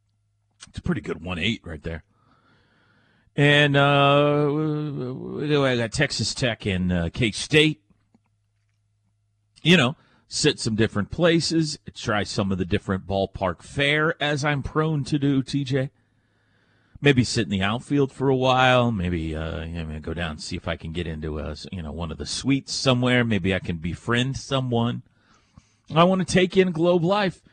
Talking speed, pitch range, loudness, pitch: 170 wpm, 95-140 Hz, -23 LUFS, 115 Hz